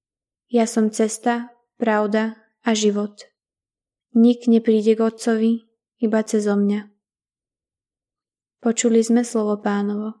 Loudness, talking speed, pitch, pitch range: -20 LUFS, 100 wpm, 225 Hz, 215-230 Hz